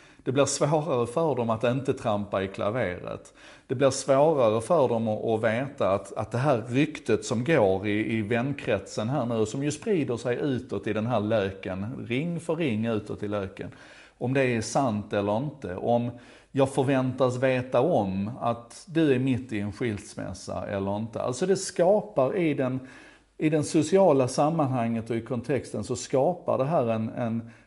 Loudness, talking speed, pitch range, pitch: -27 LUFS, 175 wpm, 110-140 Hz, 125 Hz